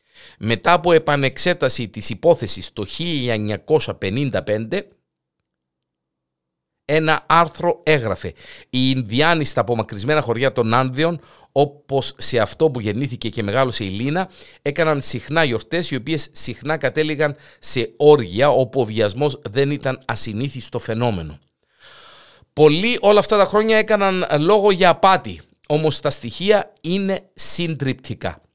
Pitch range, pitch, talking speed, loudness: 115-160 Hz, 140 Hz, 120 wpm, -18 LUFS